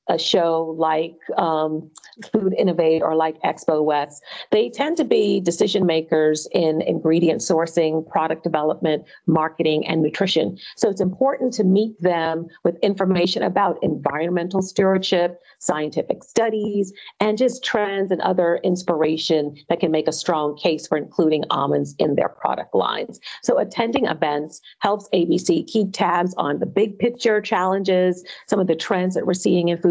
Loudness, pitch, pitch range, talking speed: -21 LUFS, 175 Hz, 160-200 Hz, 155 wpm